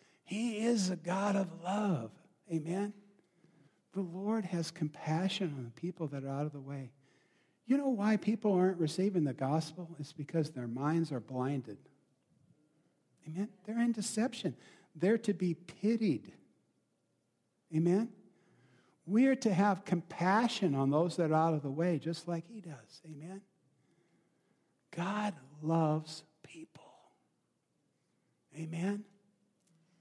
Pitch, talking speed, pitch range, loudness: 170 Hz, 130 wpm, 155-200 Hz, -34 LUFS